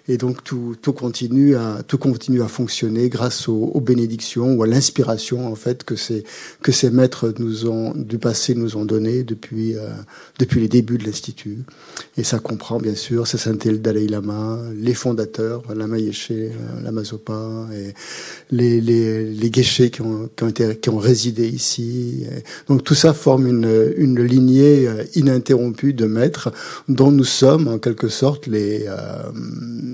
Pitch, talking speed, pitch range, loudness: 120 Hz, 170 wpm, 110-125 Hz, -18 LUFS